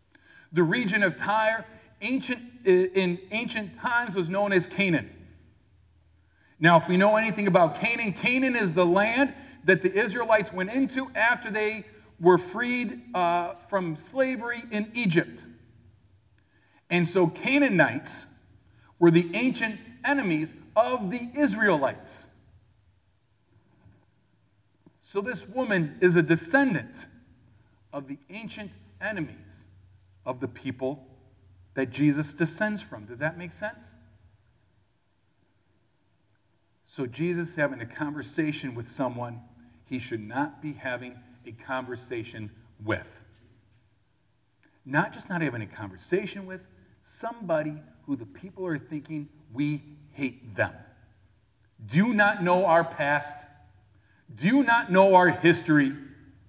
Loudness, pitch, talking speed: -26 LUFS, 150 Hz, 115 wpm